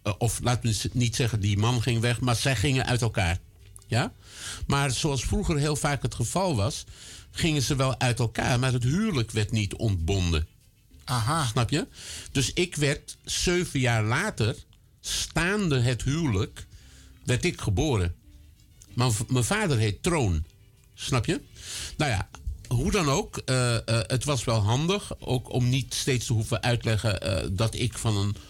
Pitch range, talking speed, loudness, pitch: 105-130 Hz, 170 wpm, -27 LUFS, 120 Hz